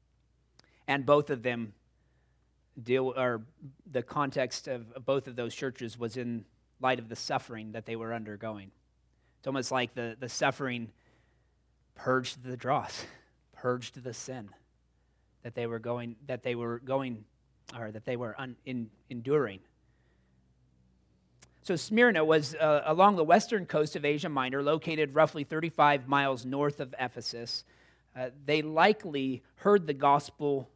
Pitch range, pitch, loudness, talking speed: 115-145 Hz, 125 Hz, -30 LUFS, 145 wpm